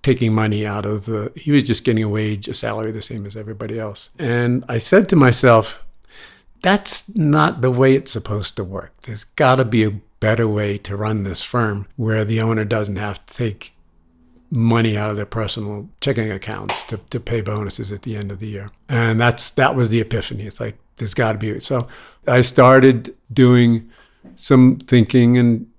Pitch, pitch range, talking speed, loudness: 115 Hz, 105-125 Hz, 195 wpm, -17 LUFS